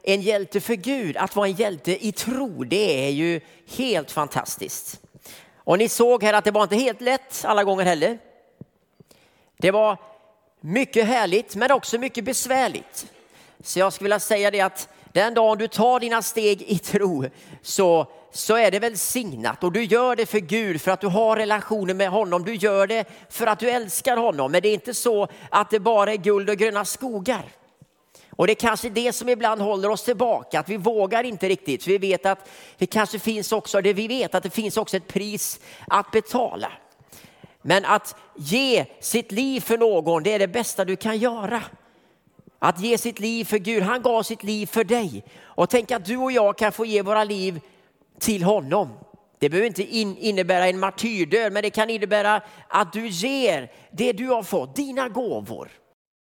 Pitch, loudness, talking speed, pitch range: 215 Hz, -22 LUFS, 195 wpm, 195-230 Hz